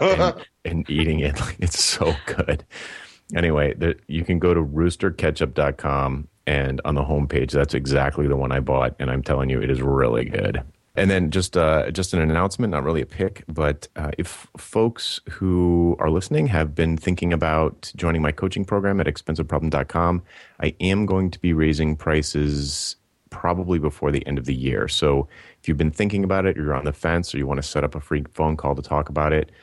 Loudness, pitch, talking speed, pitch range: -22 LUFS, 80 Hz, 205 wpm, 70-90 Hz